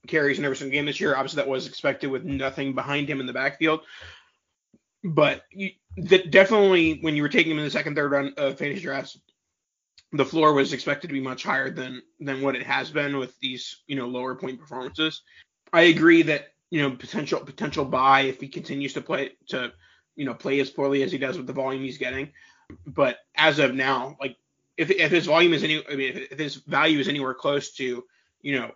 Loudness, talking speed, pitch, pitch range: -24 LUFS, 220 wpm, 140 Hz, 135-155 Hz